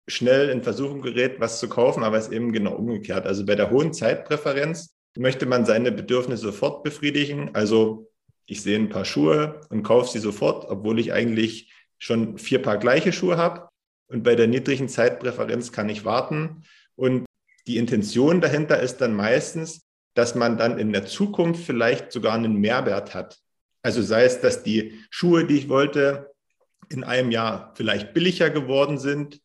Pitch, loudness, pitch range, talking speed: 125 Hz, -22 LUFS, 110-145 Hz, 175 wpm